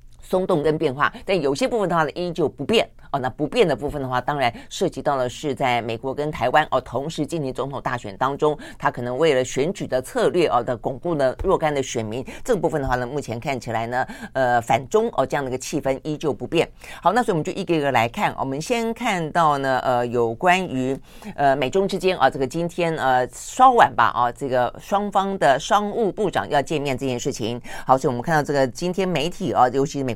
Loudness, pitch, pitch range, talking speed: -22 LUFS, 145 Hz, 130-170 Hz, 340 characters per minute